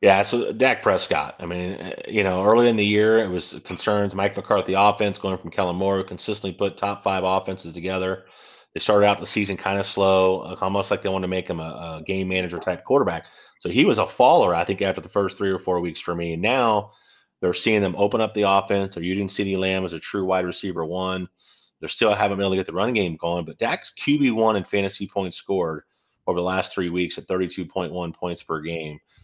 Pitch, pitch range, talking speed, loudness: 95 Hz, 90-100 Hz, 240 wpm, -23 LUFS